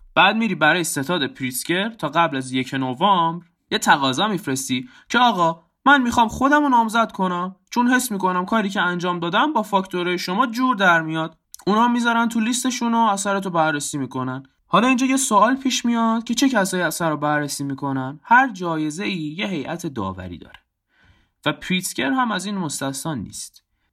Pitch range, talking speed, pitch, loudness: 155-230 Hz, 175 wpm, 180 Hz, -20 LUFS